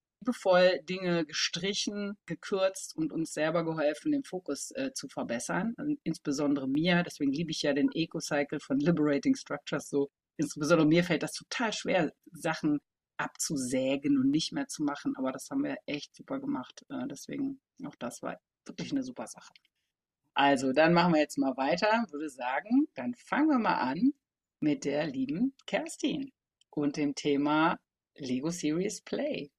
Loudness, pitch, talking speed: -31 LUFS, 175 Hz, 160 wpm